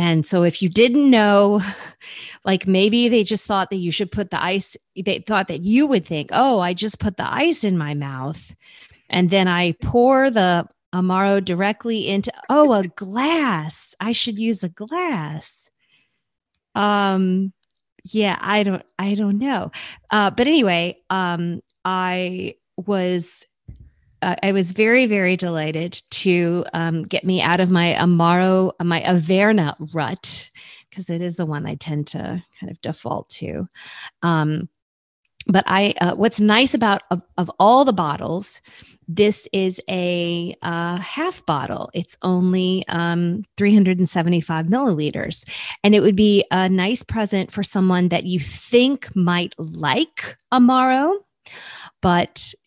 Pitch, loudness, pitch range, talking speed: 185 Hz, -19 LUFS, 175-210 Hz, 145 wpm